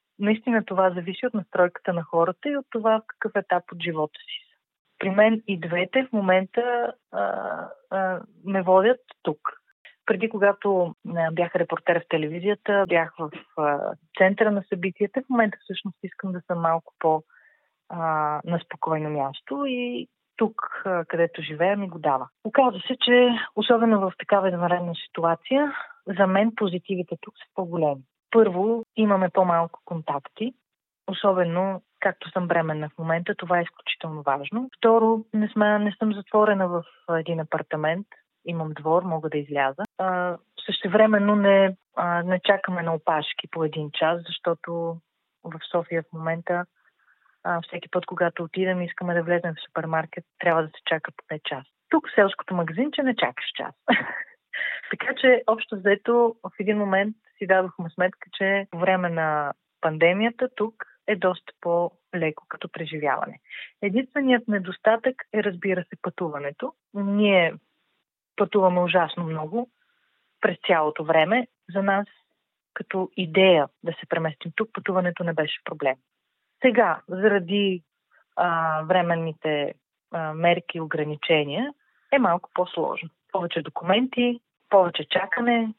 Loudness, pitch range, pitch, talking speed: -24 LUFS, 165-210 Hz, 185 Hz, 140 wpm